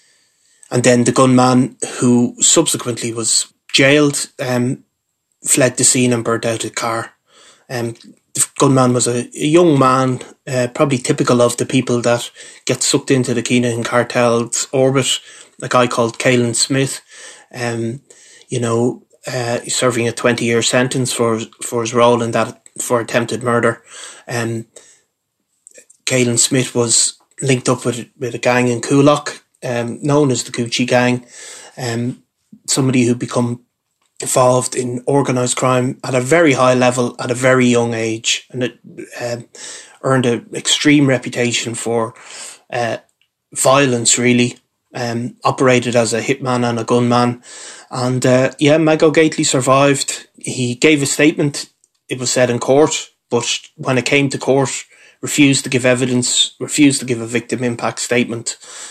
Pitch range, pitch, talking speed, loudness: 120-130 Hz, 125 Hz, 150 wpm, -15 LUFS